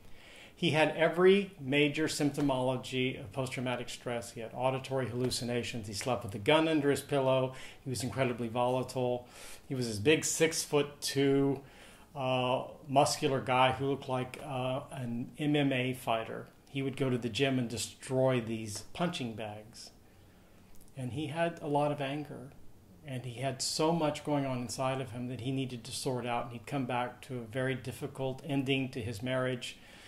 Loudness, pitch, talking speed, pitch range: -33 LUFS, 130 Hz, 175 wpm, 120-140 Hz